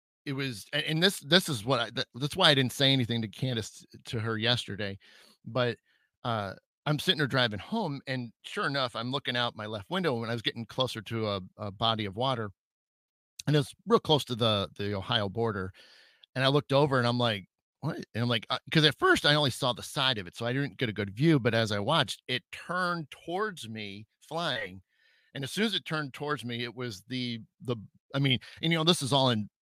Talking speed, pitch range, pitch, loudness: 235 wpm, 110-145 Hz, 125 Hz, -29 LUFS